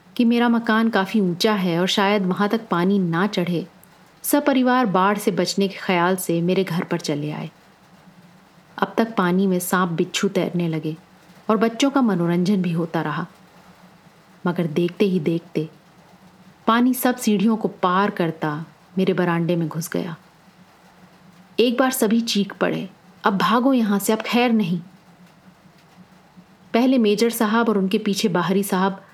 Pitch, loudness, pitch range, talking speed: 185 Hz, -21 LUFS, 175-215 Hz, 155 wpm